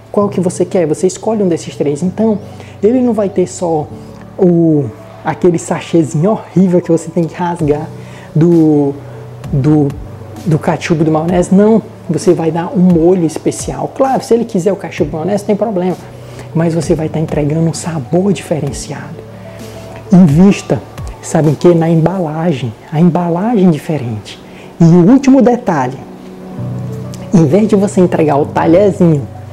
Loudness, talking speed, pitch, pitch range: -12 LUFS, 150 wpm, 165 Hz, 140-185 Hz